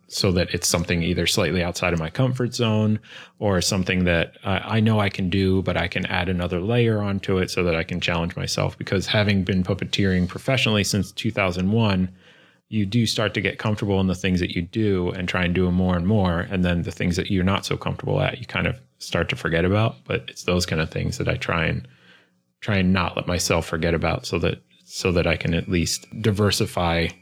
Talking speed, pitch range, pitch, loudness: 225 wpm, 90-105 Hz, 95 Hz, -22 LUFS